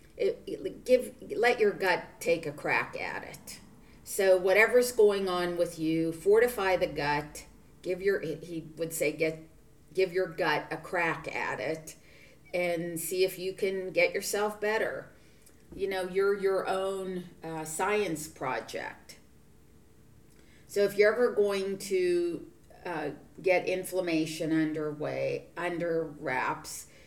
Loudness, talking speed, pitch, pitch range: -30 LUFS, 135 wpm, 185 Hz, 160-205 Hz